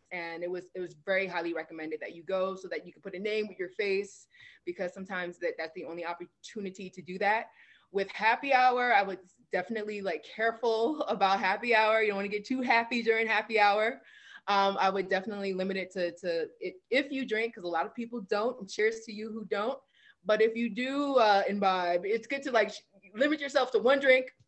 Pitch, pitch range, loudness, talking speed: 210 Hz, 185-235 Hz, -30 LUFS, 220 wpm